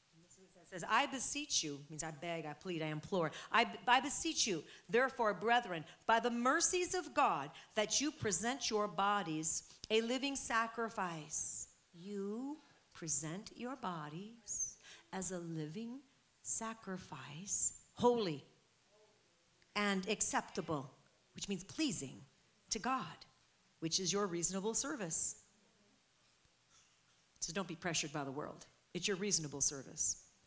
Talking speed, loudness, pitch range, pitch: 125 wpm, -37 LUFS, 165-235 Hz, 195 Hz